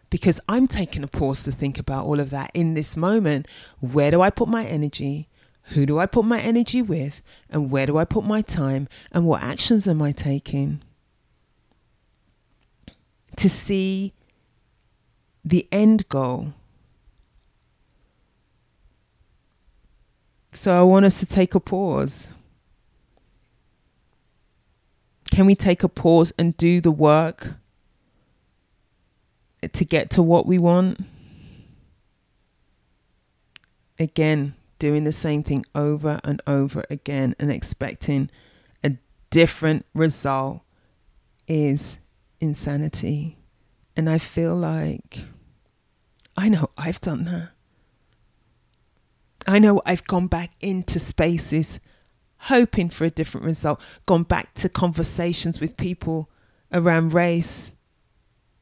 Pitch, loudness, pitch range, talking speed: 155 Hz, -21 LUFS, 140-180 Hz, 115 wpm